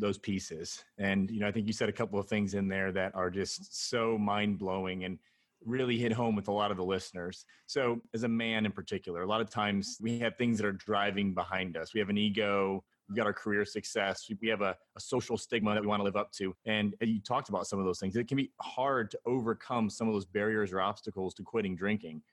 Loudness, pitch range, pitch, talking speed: -33 LUFS, 95-110 Hz, 105 Hz, 255 wpm